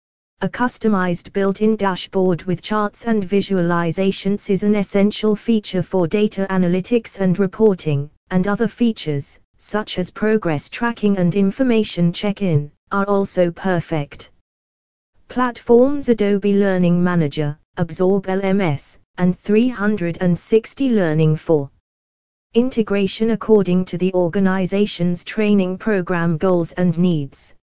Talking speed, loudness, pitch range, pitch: 115 wpm, -19 LUFS, 175-210 Hz, 190 Hz